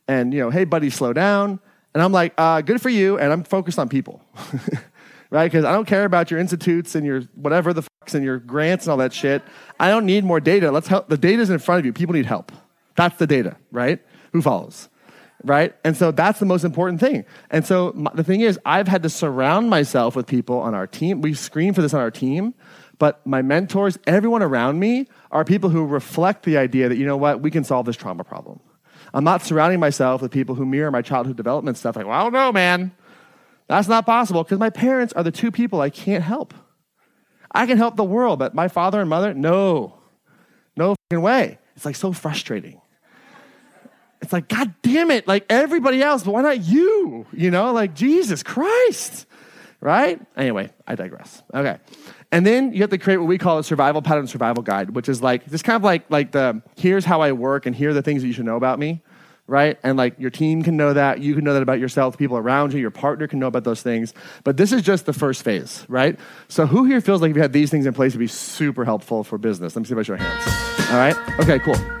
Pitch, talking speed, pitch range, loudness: 165 Hz, 240 wpm, 140-195 Hz, -19 LUFS